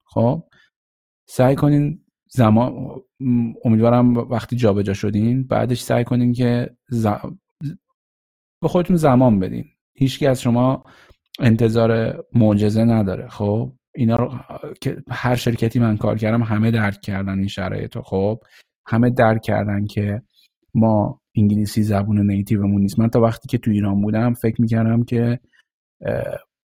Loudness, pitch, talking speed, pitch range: -19 LUFS, 115 Hz, 130 wpm, 105-125 Hz